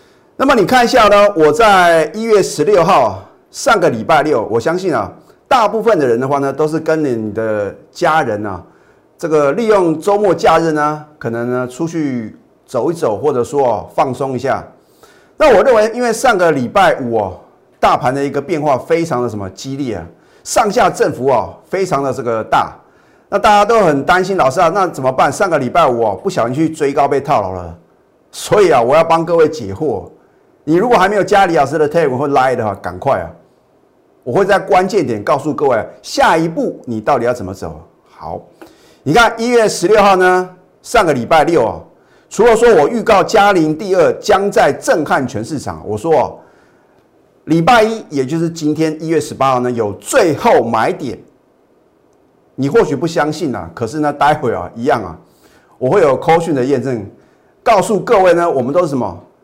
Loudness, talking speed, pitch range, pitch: -13 LUFS, 285 characters per minute, 130-190 Hz, 155 Hz